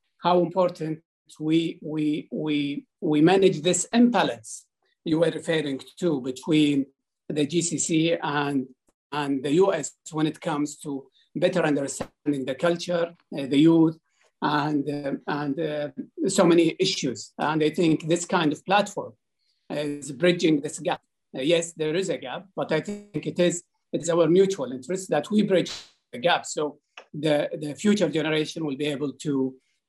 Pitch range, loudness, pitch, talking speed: 145-175 Hz, -25 LUFS, 155 Hz, 155 wpm